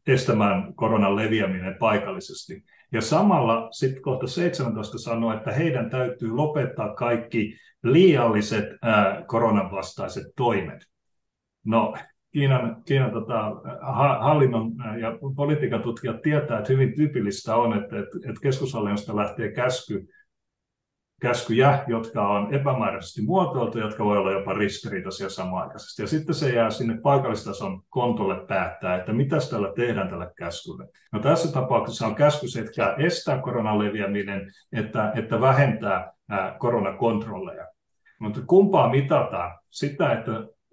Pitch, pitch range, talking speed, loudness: 115 Hz, 105-135 Hz, 120 wpm, -24 LUFS